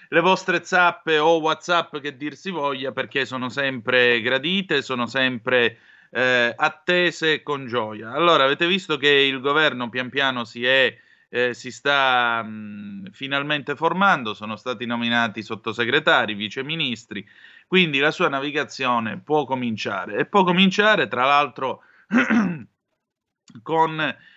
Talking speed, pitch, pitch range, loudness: 130 wpm, 140 Hz, 125-165 Hz, -21 LUFS